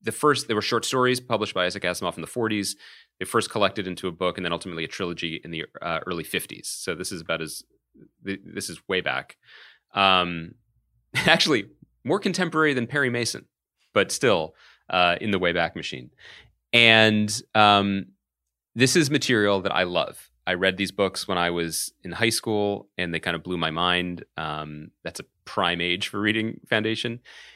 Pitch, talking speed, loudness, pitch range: 100 Hz, 185 wpm, -24 LUFS, 85-110 Hz